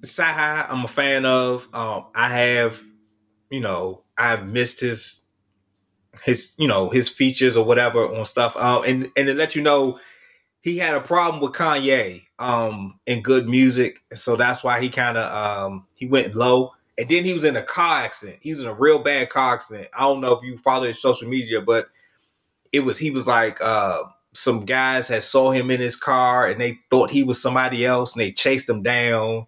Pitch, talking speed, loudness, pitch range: 125 Hz, 205 wpm, -19 LUFS, 115-135 Hz